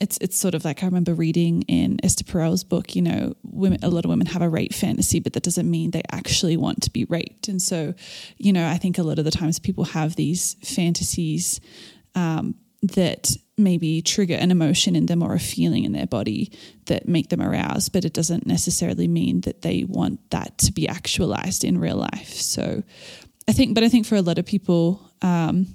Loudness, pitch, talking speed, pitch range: -22 LUFS, 175 Hz, 215 wpm, 165-190 Hz